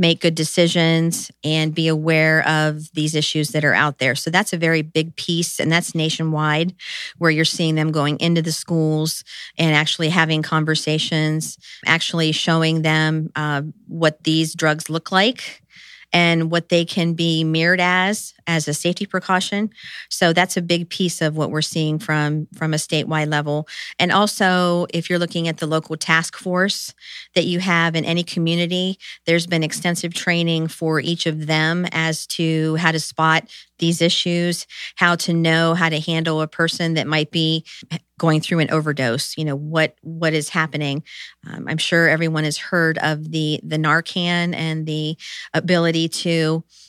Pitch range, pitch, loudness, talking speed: 155-170 Hz, 160 Hz, -19 LUFS, 170 wpm